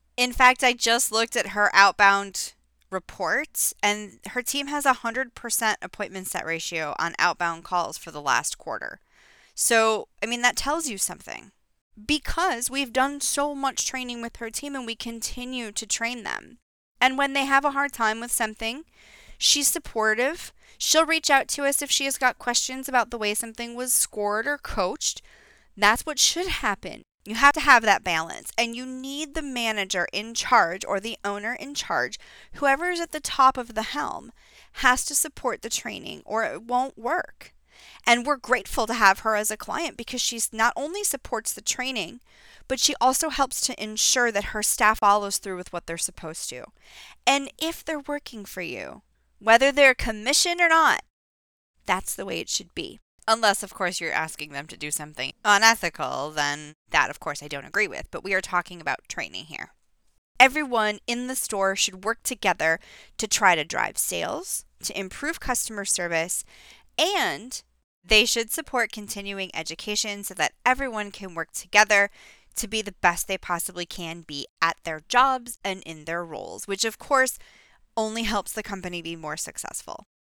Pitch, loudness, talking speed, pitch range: 225 Hz, -24 LUFS, 180 wpm, 195-265 Hz